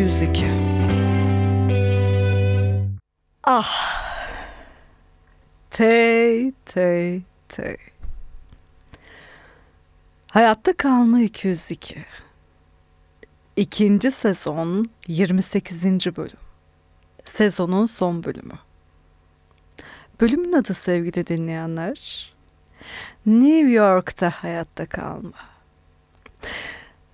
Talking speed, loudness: 50 wpm, -20 LUFS